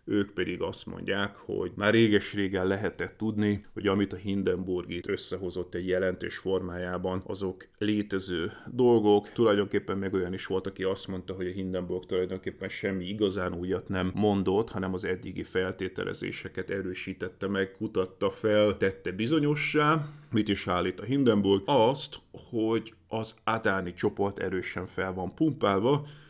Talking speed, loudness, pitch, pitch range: 145 wpm, -29 LUFS, 95 Hz, 95-105 Hz